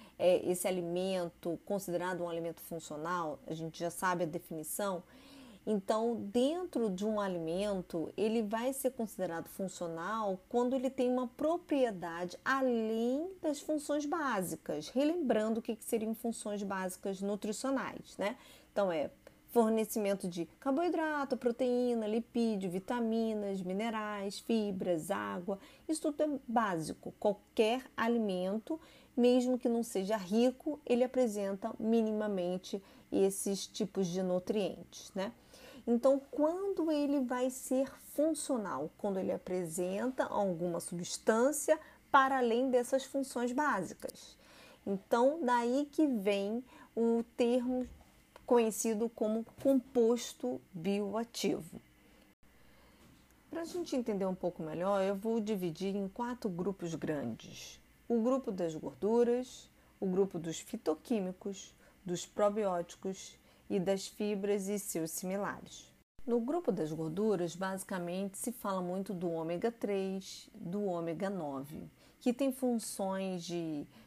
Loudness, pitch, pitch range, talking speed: -35 LUFS, 215 Hz, 185-250 Hz, 115 wpm